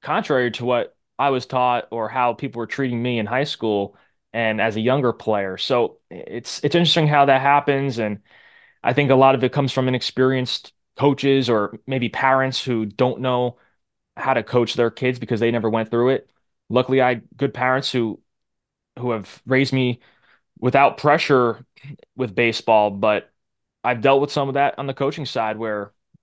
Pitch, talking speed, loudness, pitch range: 125 Hz, 185 wpm, -20 LUFS, 115-135 Hz